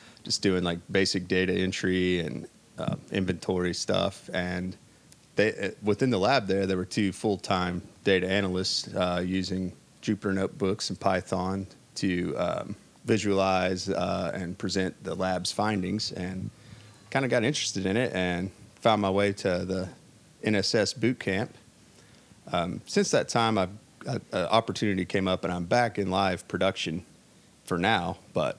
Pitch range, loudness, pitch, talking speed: 90-105 Hz, -28 LUFS, 95 Hz, 150 wpm